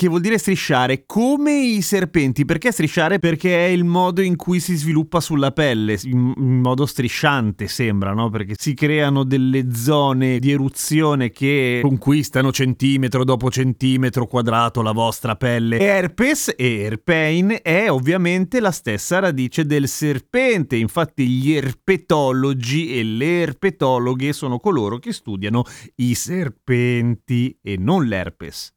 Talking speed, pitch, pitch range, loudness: 135 wpm, 135 Hz, 125-170 Hz, -18 LUFS